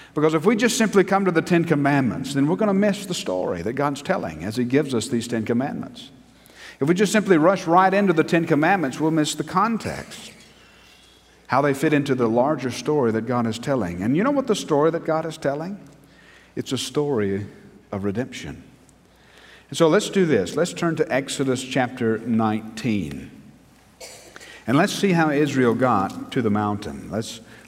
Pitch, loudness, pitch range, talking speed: 140 Hz, -21 LUFS, 115-165 Hz, 190 wpm